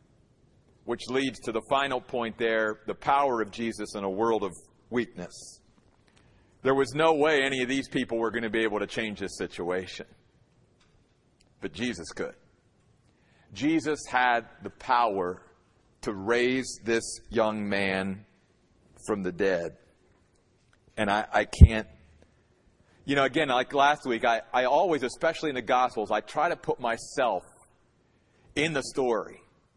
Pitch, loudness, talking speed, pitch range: 115 Hz, -27 LUFS, 145 wpm, 100-130 Hz